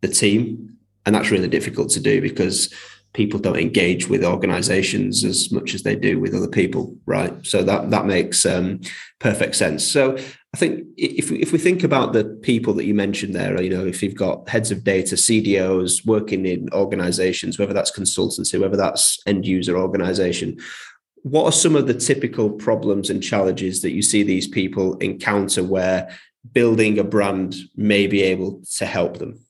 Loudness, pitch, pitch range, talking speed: -19 LUFS, 100 Hz, 95-115 Hz, 180 wpm